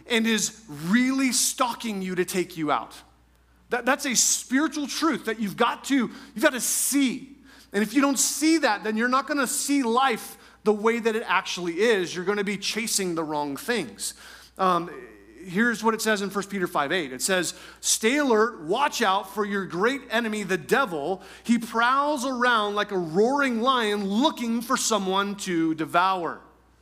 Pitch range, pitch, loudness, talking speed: 190-260 Hz, 225 Hz, -24 LUFS, 180 wpm